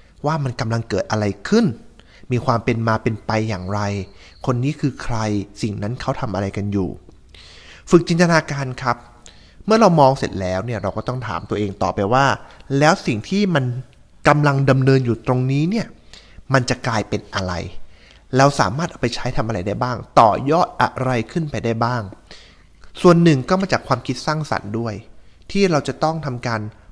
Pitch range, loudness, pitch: 100-140 Hz, -19 LUFS, 120 Hz